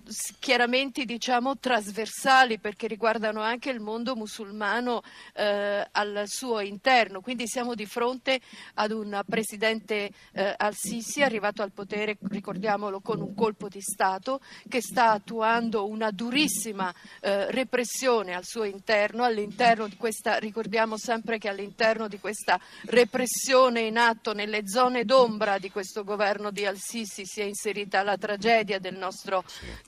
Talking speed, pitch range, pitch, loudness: 135 wpm, 205-235 Hz, 220 Hz, -27 LUFS